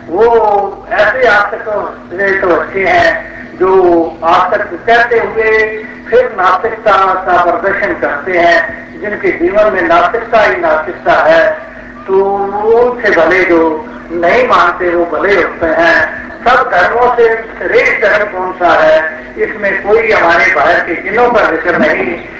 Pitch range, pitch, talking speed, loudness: 175-225 Hz, 200 Hz, 135 wpm, -10 LUFS